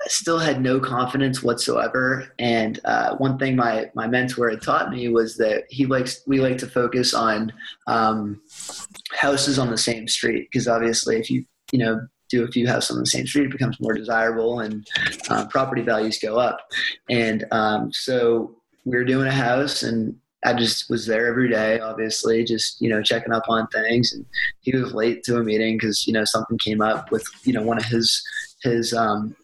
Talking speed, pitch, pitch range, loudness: 200 wpm, 115 Hz, 110-125 Hz, -22 LUFS